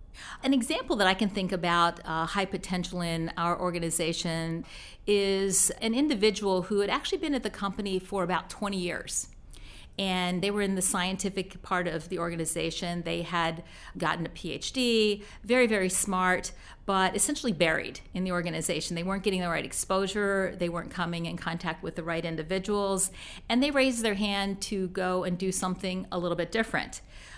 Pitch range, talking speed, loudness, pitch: 170-200 Hz, 175 wpm, -28 LUFS, 185 Hz